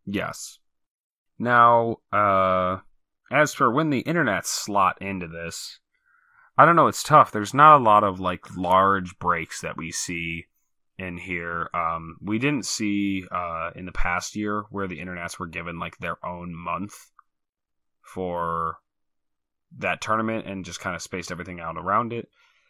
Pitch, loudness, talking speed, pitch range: 95 Hz, -23 LUFS, 155 wpm, 85-105 Hz